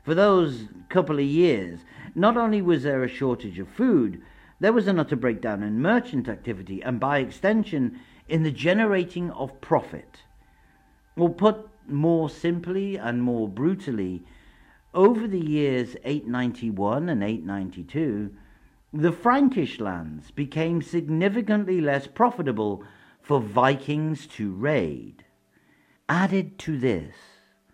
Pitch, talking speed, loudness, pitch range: 145 Hz, 120 wpm, -24 LUFS, 115-180 Hz